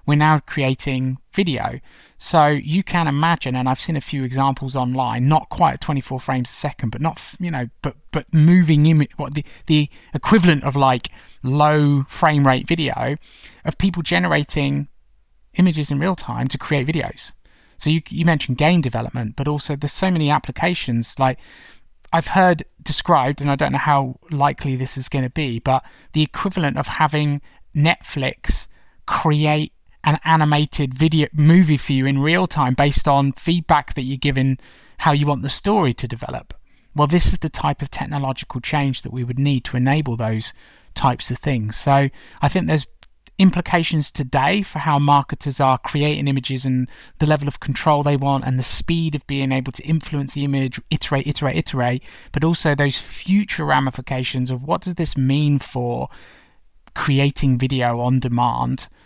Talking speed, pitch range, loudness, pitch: 175 wpm, 130-155 Hz, -19 LUFS, 145 Hz